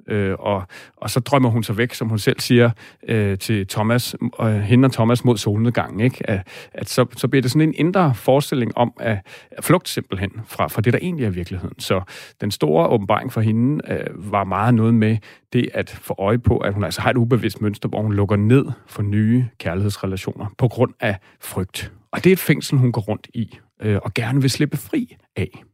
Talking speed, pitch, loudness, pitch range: 215 wpm, 115 Hz, -20 LUFS, 105-125 Hz